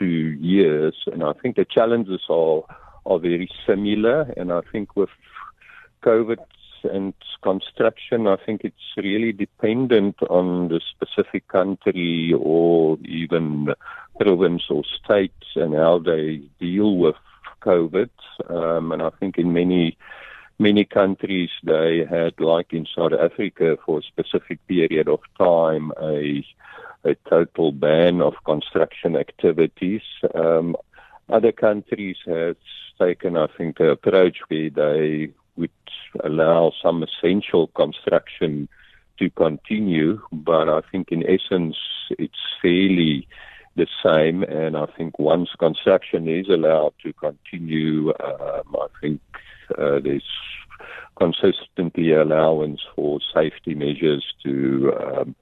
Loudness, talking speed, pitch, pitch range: -21 LUFS, 120 wpm, 85 Hz, 80-95 Hz